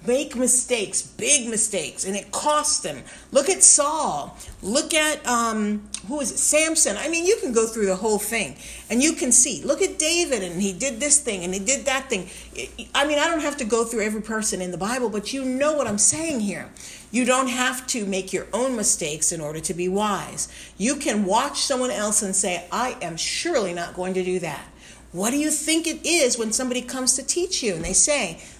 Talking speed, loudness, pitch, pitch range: 225 wpm, -21 LUFS, 245 Hz, 200-290 Hz